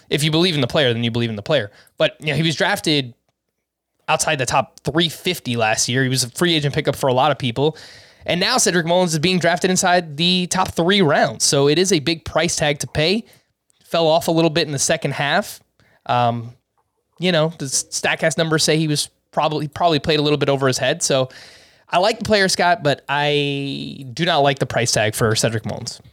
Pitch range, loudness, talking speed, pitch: 135-170 Hz, -18 LUFS, 230 wpm, 155 Hz